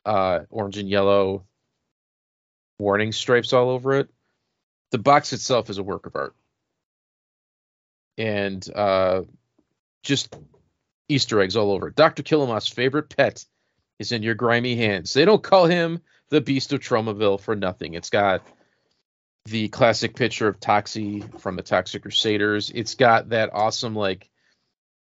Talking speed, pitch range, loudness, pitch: 140 wpm, 100-130 Hz, -22 LUFS, 110 Hz